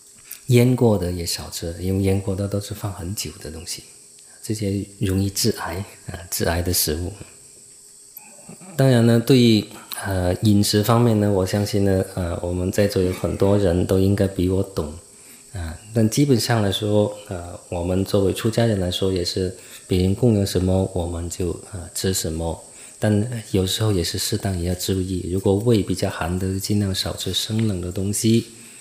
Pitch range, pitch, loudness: 90-105 Hz, 100 Hz, -21 LUFS